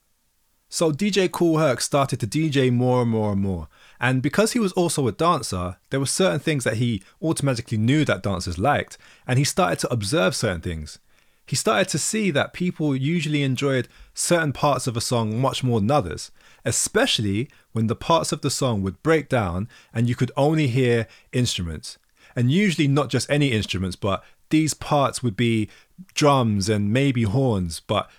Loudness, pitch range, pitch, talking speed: -22 LUFS, 110-155 Hz, 130 Hz, 185 wpm